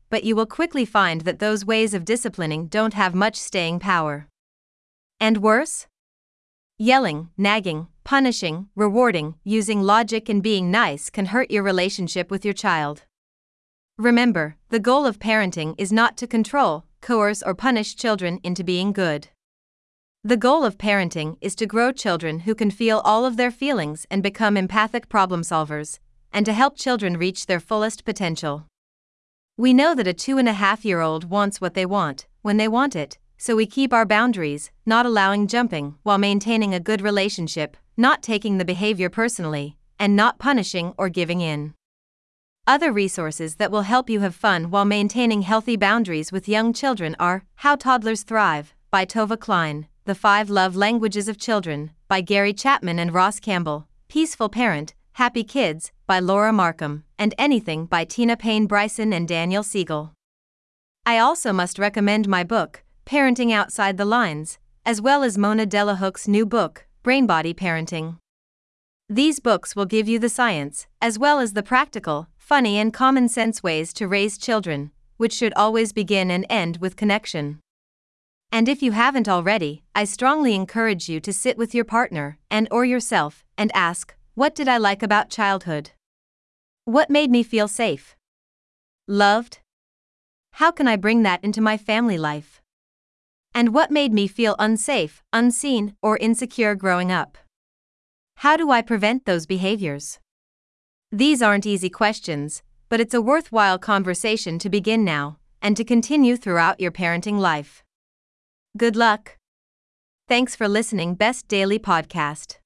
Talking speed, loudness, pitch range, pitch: 160 wpm, -21 LUFS, 180-230 Hz, 210 Hz